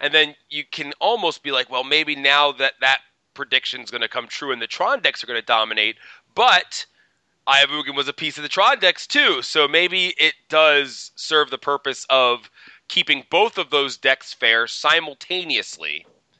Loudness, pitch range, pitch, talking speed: -18 LUFS, 140-155 Hz, 150 Hz, 185 wpm